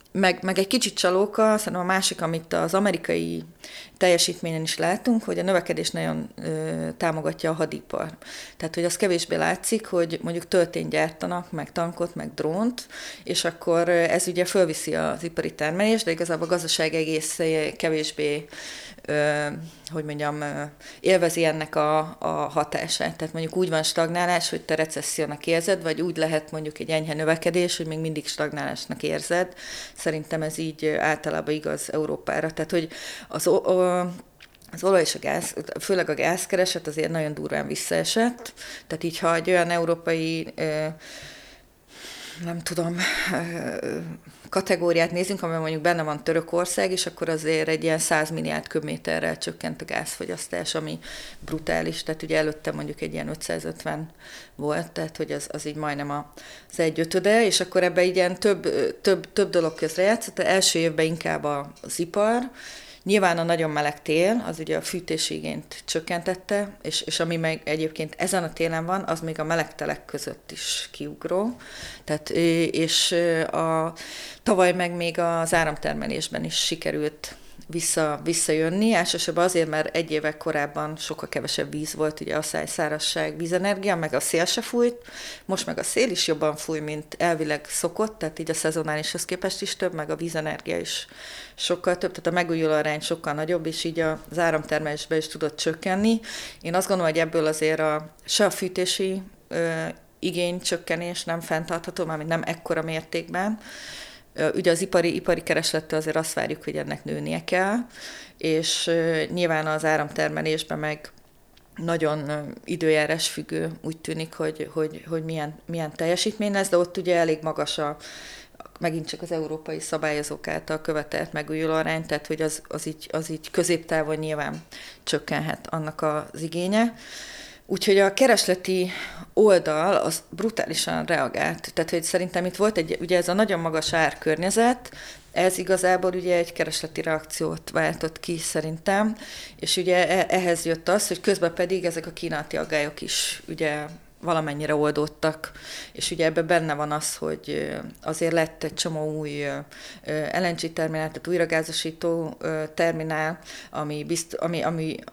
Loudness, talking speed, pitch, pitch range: -25 LUFS, 150 wpm, 165 Hz, 155-180 Hz